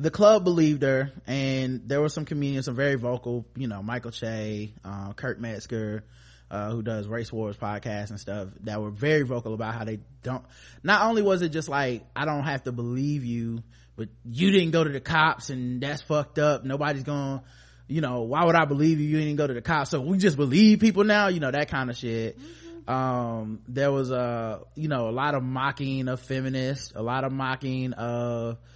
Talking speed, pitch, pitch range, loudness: 215 wpm, 130 Hz, 115-150 Hz, -26 LUFS